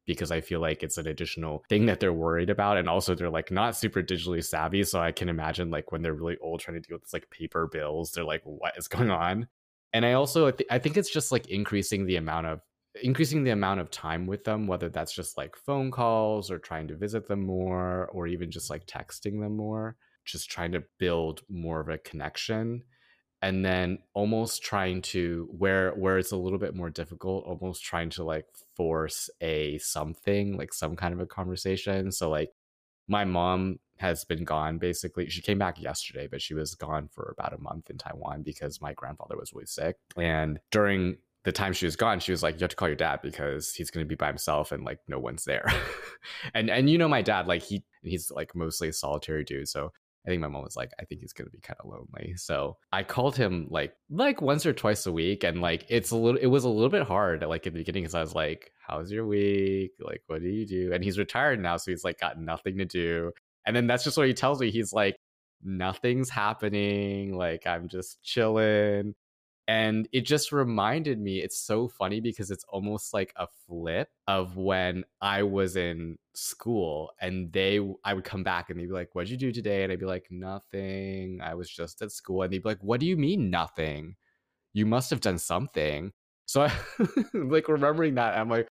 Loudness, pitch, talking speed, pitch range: -29 LUFS, 95 Hz, 225 wpm, 85-105 Hz